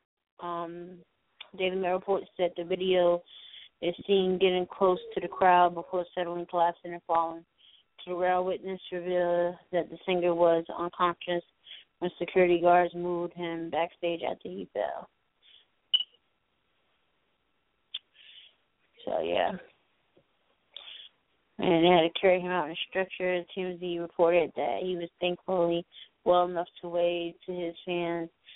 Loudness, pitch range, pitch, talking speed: -29 LUFS, 170-180 Hz, 175 Hz, 130 wpm